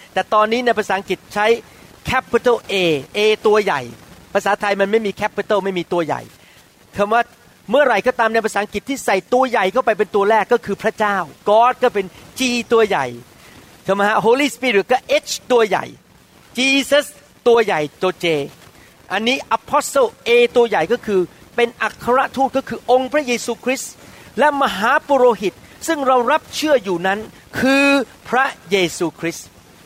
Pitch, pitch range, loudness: 225 Hz, 195-255 Hz, -17 LUFS